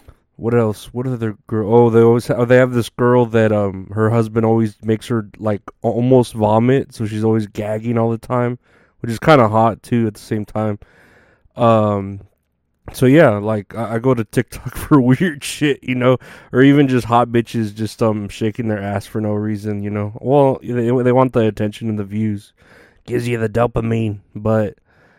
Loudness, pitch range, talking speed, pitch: -17 LUFS, 105-120 Hz, 195 wpm, 115 Hz